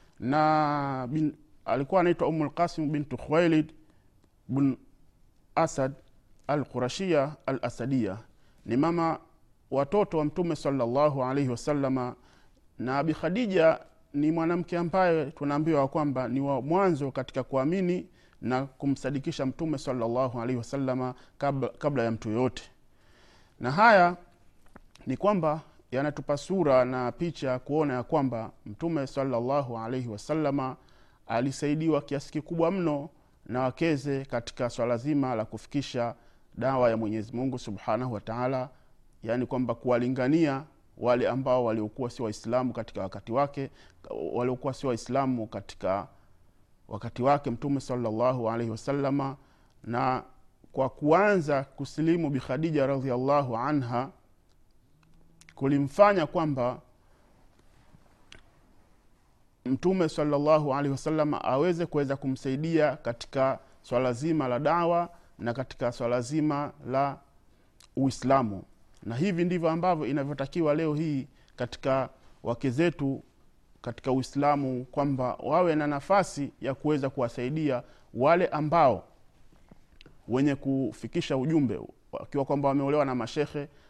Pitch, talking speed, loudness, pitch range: 135 Hz, 100 wpm, -28 LUFS, 125-150 Hz